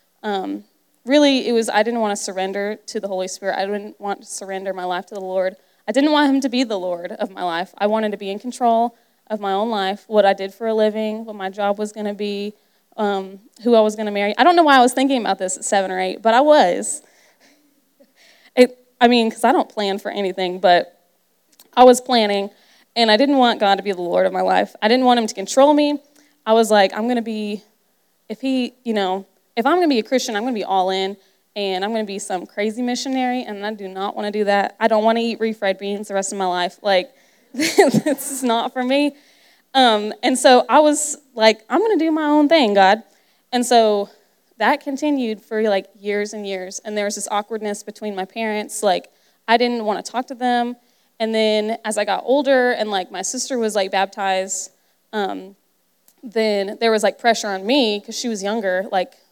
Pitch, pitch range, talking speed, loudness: 215 Hz, 200-245 Hz, 235 wpm, -19 LUFS